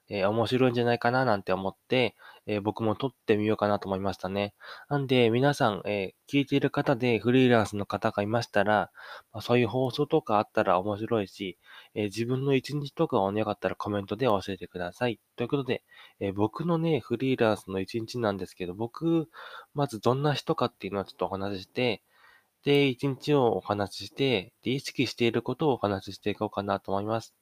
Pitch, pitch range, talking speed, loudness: 115 Hz, 100-130 Hz, 410 characters per minute, -28 LUFS